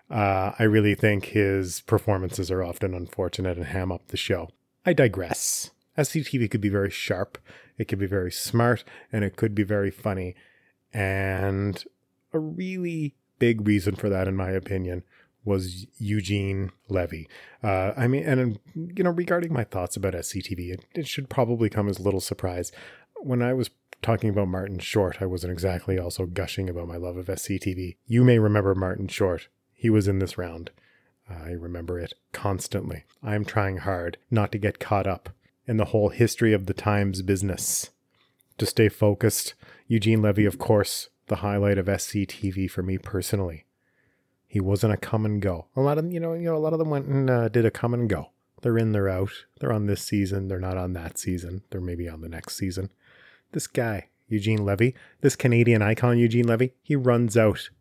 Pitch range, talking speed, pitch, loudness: 95-115 Hz, 190 wpm, 100 Hz, -26 LUFS